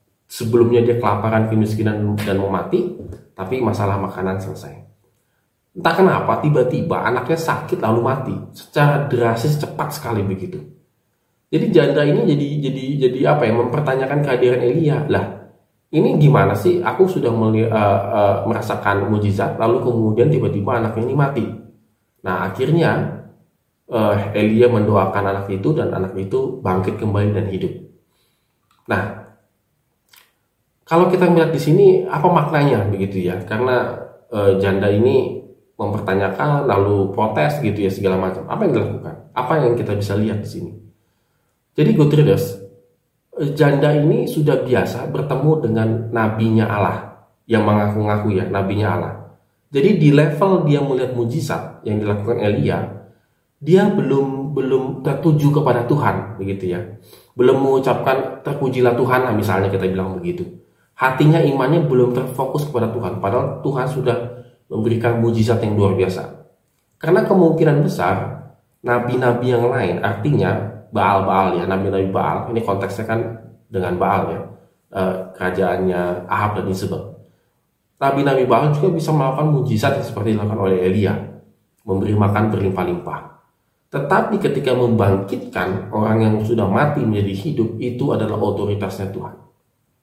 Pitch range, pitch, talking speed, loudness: 100-135 Hz, 115 Hz, 135 wpm, -18 LUFS